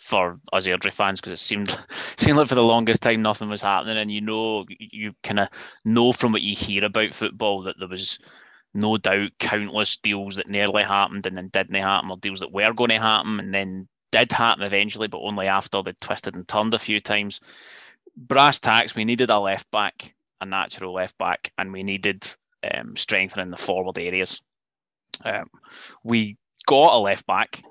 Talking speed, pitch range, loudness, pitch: 195 wpm, 95-110 Hz, -22 LUFS, 105 Hz